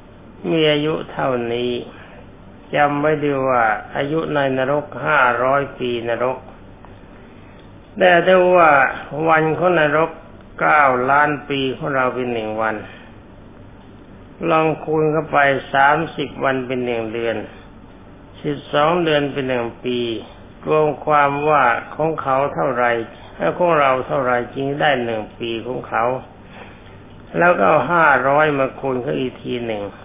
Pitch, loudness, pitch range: 130 Hz, -18 LUFS, 115-150 Hz